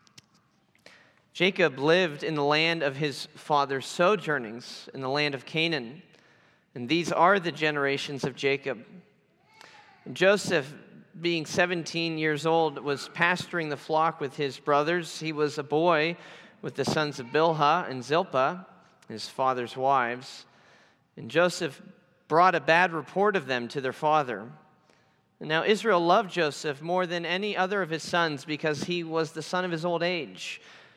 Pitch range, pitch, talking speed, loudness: 145-175 Hz, 160 Hz, 155 wpm, -27 LUFS